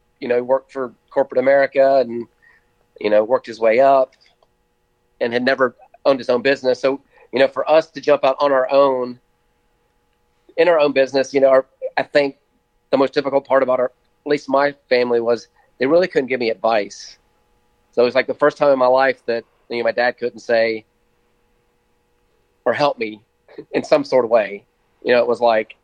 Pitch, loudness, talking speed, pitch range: 130 Hz, -18 LUFS, 200 wpm, 120-140 Hz